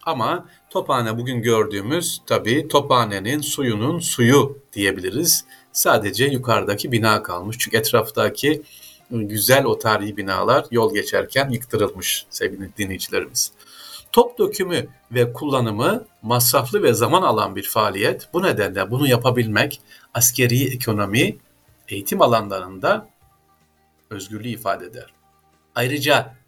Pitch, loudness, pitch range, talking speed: 120 Hz, -20 LUFS, 100-135 Hz, 105 wpm